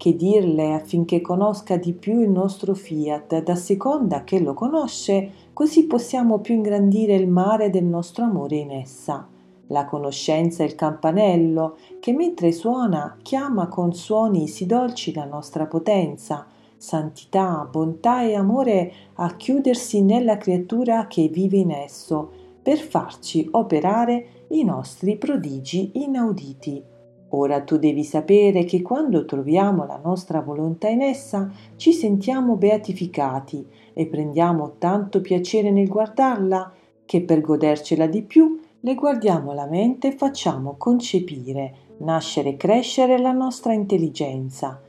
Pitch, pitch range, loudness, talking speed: 185 Hz, 155-220 Hz, -21 LUFS, 130 wpm